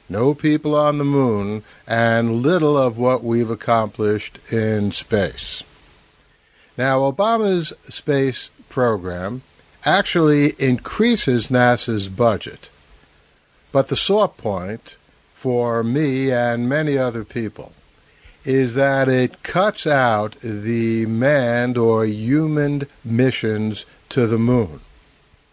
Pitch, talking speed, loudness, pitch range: 120 Hz, 105 wpm, -19 LUFS, 110-140 Hz